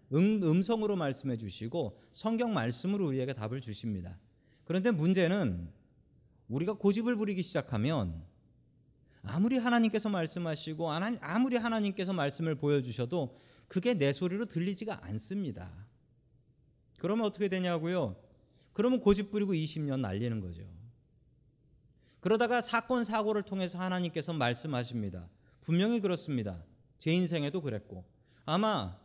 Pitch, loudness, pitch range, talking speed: 160 Hz, -32 LUFS, 120-200 Hz, 320 characters per minute